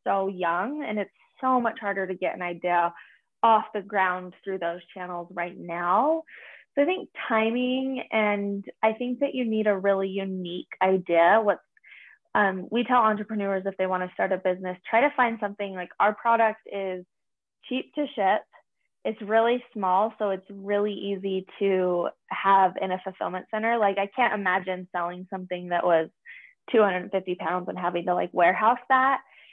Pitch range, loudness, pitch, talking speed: 185-225 Hz, -26 LUFS, 195 Hz, 175 wpm